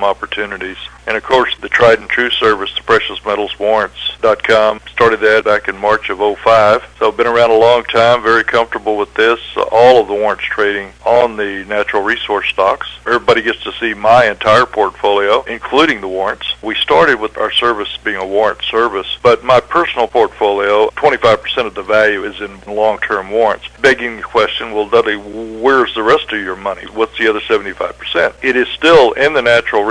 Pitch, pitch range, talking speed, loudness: 110 Hz, 105-115 Hz, 190 wpm, -13 LUFS